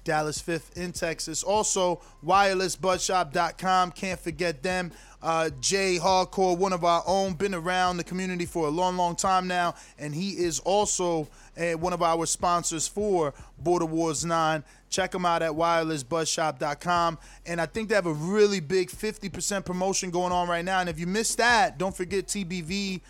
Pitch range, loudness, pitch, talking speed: 165-190 Hz, -26 LUFS, 180 Hz, 170 wpm